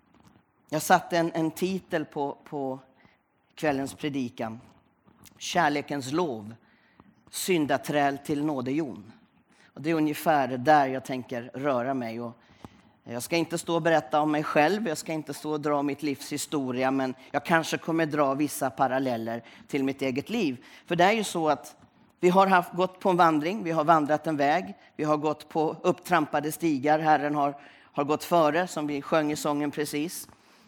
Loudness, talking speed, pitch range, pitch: -27 LUFS, 170 wpm, 135-165 Hz, 150 Hz